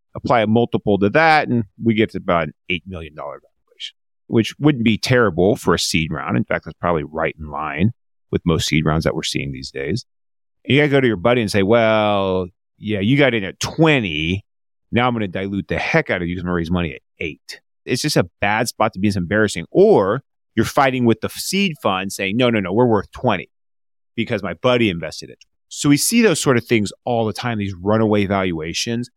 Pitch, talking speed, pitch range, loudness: 105 Hz, 230 wpm, 90-120 Hz, -18 LUFS